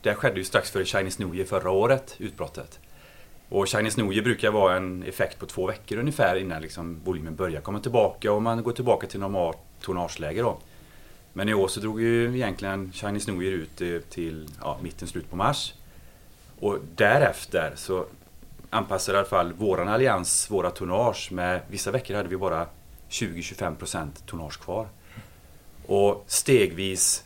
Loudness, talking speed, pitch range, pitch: -26 LUFS, 165 wpm, 85-105 Hz, 95 Hz